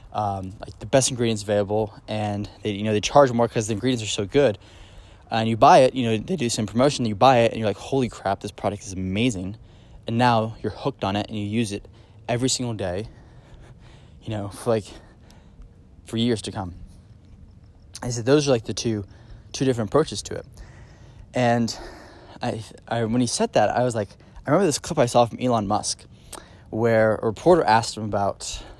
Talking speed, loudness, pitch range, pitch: 210 wpm, -23 LUFS, 100-120 Hz, 110 Hz